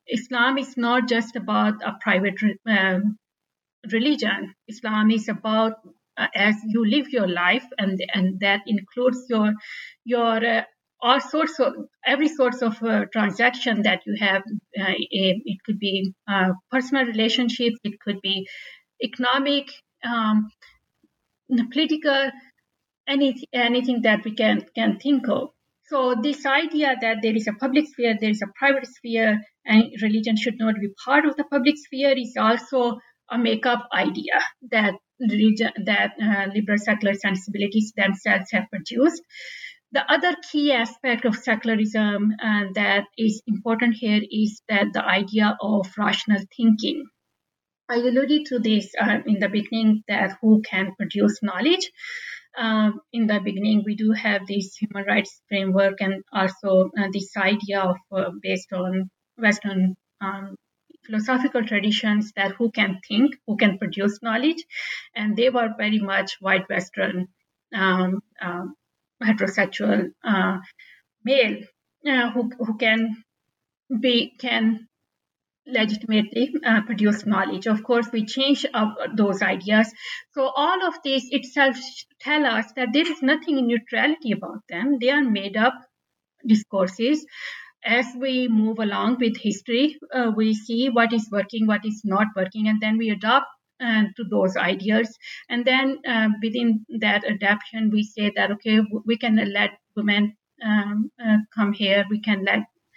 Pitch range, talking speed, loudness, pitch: 205-250 Hz, 150 wpm, -22 LUFS, 220 Hz